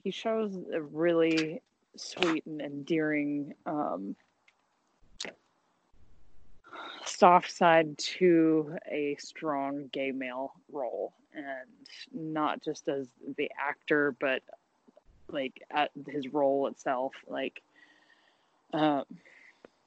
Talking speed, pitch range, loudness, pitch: 90 wpm, 140-160 Hz, -31 LUFS, 150 Hz